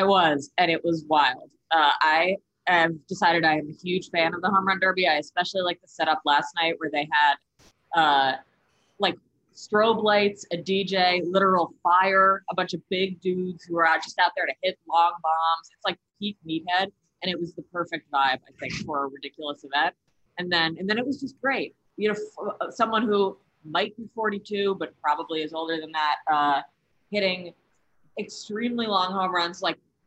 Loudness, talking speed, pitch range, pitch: -24 LUFS, 195 wpm, 160-195 Hz, 180 Hz